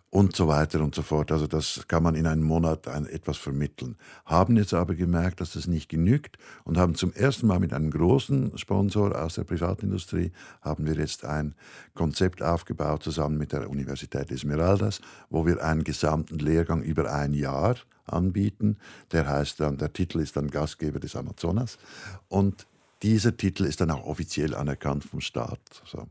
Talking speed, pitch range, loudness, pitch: 180 wpm, 75-95 Hz, -27 LUFS, 80 Hz